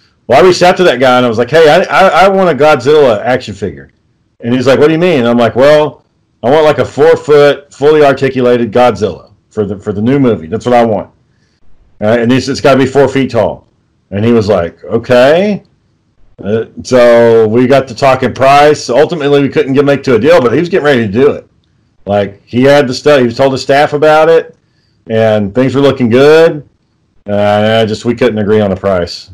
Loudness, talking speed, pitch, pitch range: -8 LUFS, 235 wpm, 125 Hz, 110-145 Hz